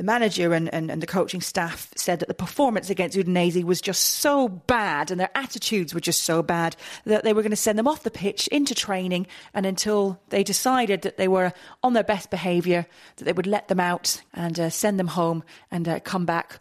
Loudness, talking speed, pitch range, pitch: -24 LUFS, 230 wpm, 175-215 Hz, 190 Hz